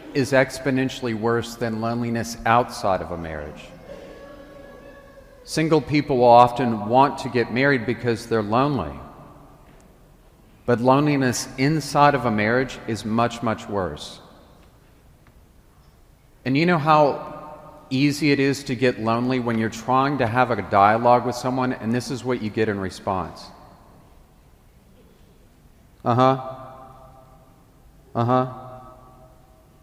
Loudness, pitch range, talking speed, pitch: -21 LUFS, 115-135 Hz, 120 wpm, 125 Hz